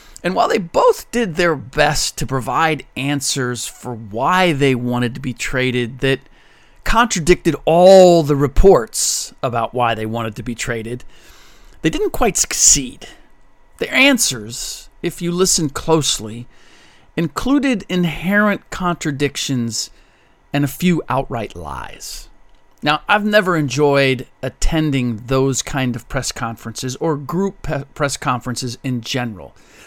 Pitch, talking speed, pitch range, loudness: 140 Hz, 130 wpm, 125-175 Hz, -17 LUFS